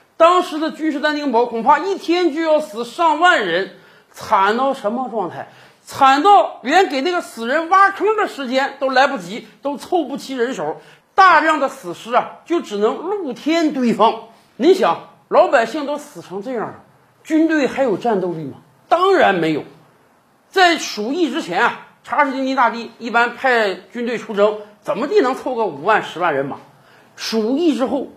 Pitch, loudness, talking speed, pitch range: 275 Hz, -17 LUFS, 250 characters per minute, 230-325 Hz